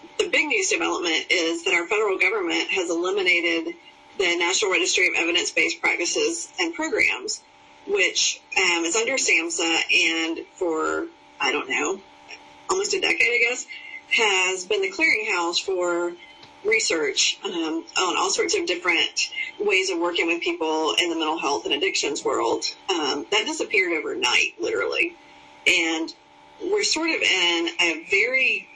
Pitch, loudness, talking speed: 345 Hz, -21 LUFS, 150 wpm